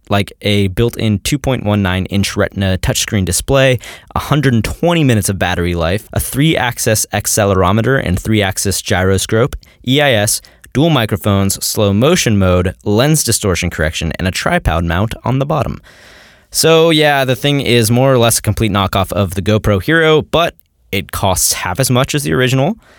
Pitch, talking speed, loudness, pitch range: 105 Hz, 160 wpm, -13 LUFS, 95-130 Hz